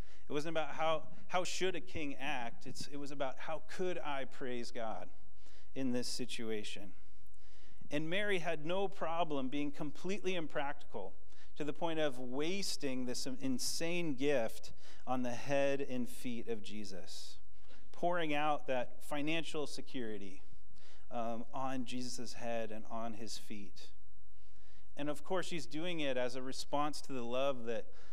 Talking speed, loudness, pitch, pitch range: 150 wpm, -40 LUFS, 130 Hz, 105-150 Hz